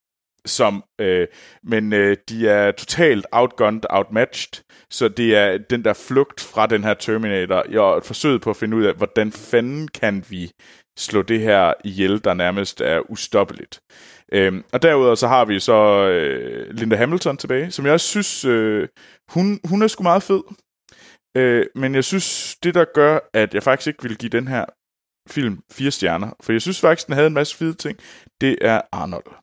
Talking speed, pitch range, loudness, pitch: 185 wpm, 105-160 Hz, -18 LUFS, 120 Hz